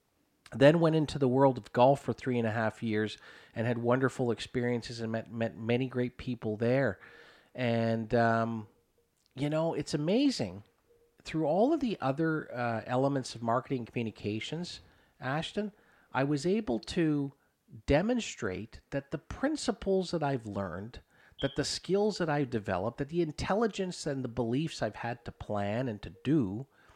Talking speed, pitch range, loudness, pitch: 160 wpm, 115-155 Hz, -32 LUFS, 130 Hz